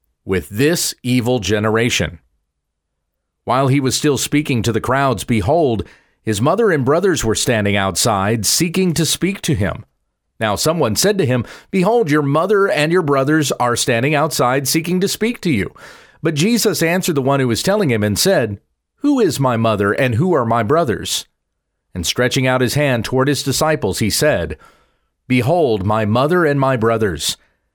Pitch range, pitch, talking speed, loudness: 110-160 Hz, 130 Hz, 175 wpm, -16 LUFS